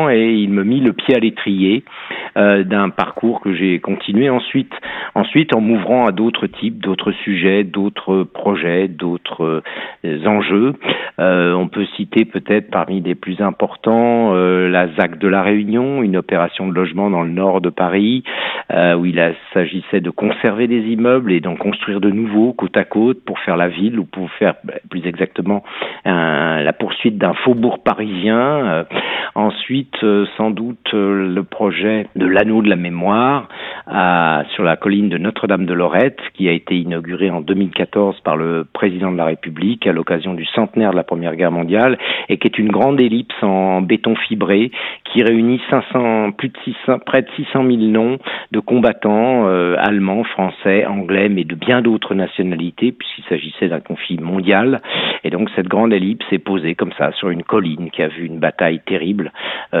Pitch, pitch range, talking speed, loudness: 100 Hz, 90-110 Hz, 180 wpm, -16 LUFS